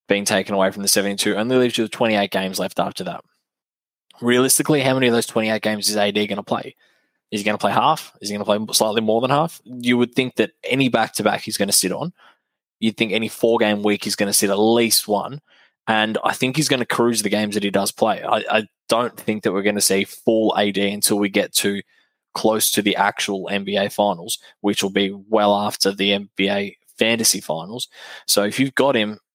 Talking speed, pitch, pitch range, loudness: 230 wpm, 105 Hz, 100-115 Hz, -19 LUFS